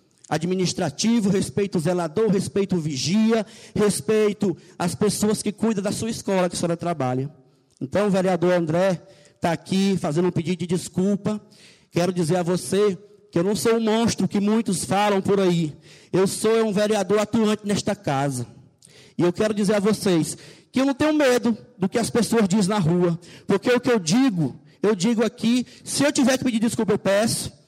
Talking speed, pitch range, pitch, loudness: 180 wpm, 175-215 Hz, 195 Hz, -22 LUFS